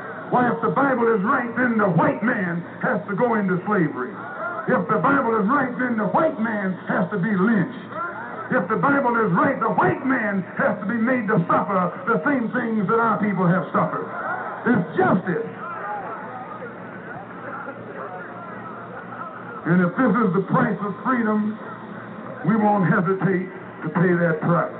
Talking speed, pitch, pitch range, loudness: 165 wpm, 210 Hz, 190-230 Hz, -21 LUFS